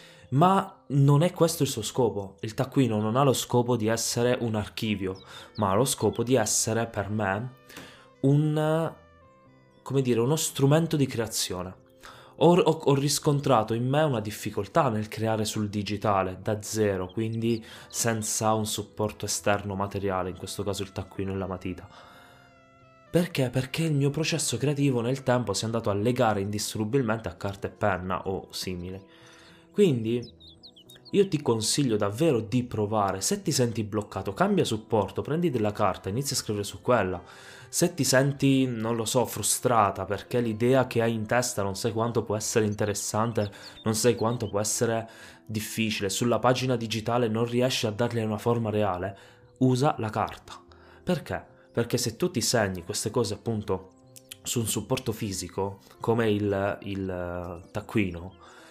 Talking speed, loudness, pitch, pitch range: 160 wpm, -27 LUFS, 110 Hz, 100-130 Hz